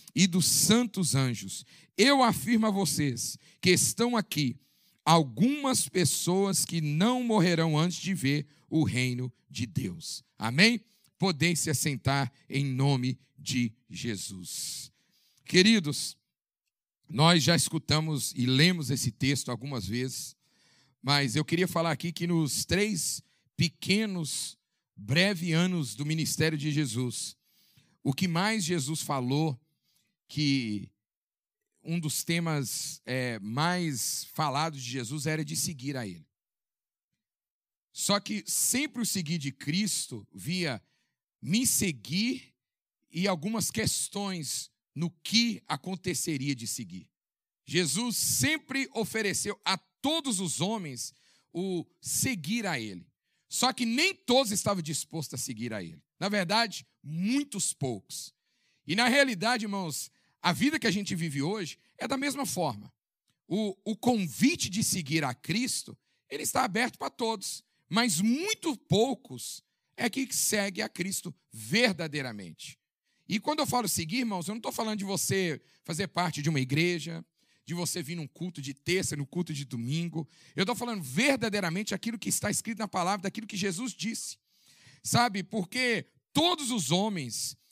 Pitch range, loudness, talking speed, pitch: 140-205 Hz, -29 LUFS, 135 wpm, 170 Hz